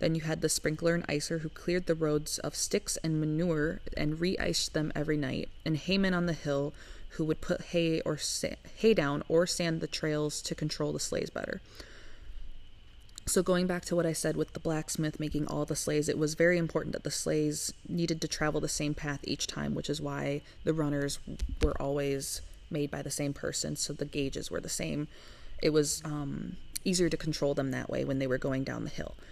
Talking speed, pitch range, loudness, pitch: 215 wpm, 140-165 Hz, -32 LUFS, 150 Hz